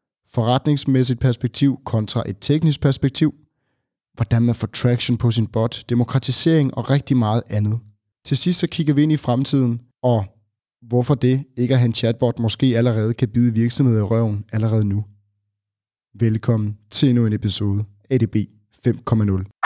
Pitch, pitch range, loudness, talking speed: 120 Hz, 110-130 Hz, -19 LUFS, 155 wpm